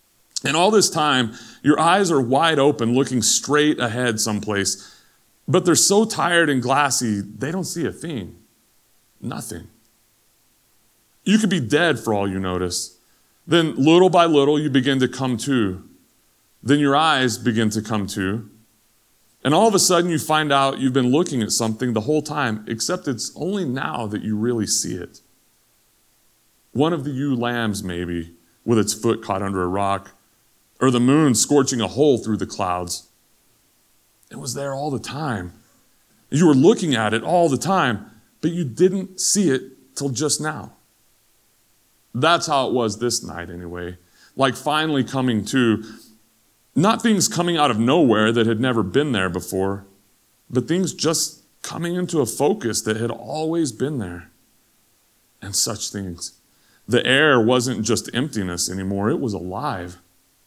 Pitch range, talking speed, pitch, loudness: 105-145 Hz, 165 wpm, 120 Hz, -20 LUFS